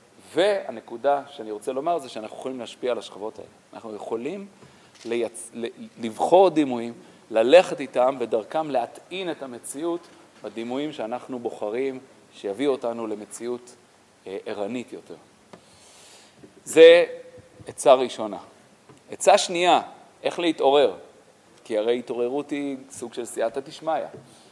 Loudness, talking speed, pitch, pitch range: -23 LUFS, 110 wpm, 135 Hz, 115-165 Hz